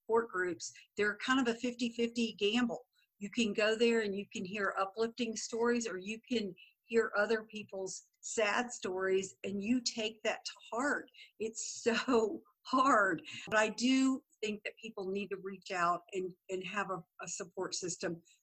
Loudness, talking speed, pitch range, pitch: -35 LUFS, 170 wpm, 195-235 Hz, 215 Hz